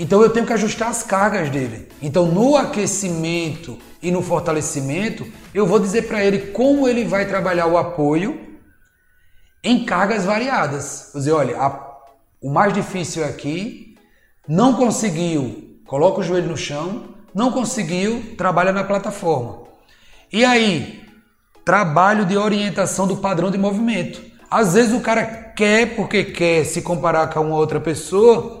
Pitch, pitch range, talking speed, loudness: 195 Hz, 165-220 Hz, 145 wpm, -18 LUFS